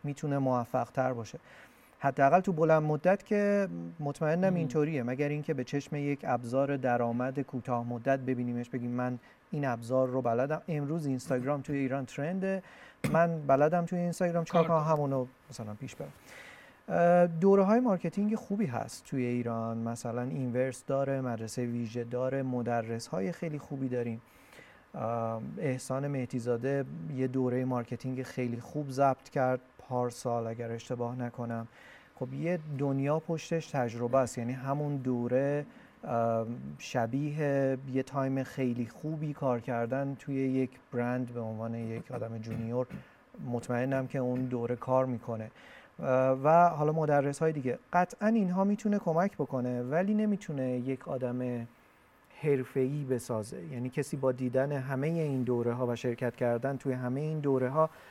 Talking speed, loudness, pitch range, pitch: 140 wpm, -32 LUFS, 120-150 Hz, 130 Hz